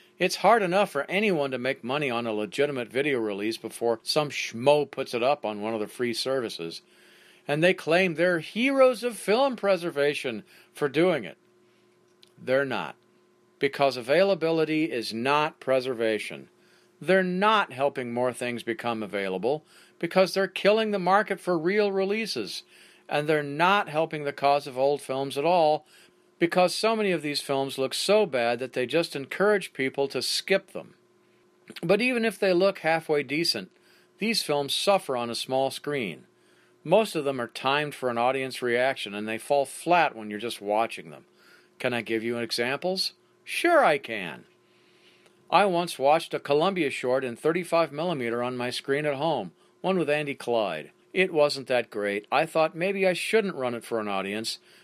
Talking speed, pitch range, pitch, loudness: 175 wpm, 125-180 Hz, 145 Hz, -26 LUFS